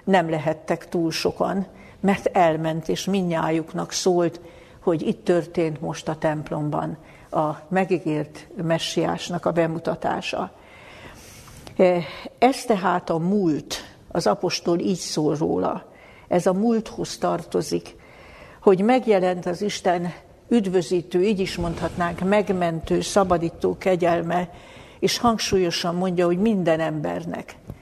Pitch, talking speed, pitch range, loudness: 175 Hz, 110 wpm, 160-190 Hz, -23 LUFS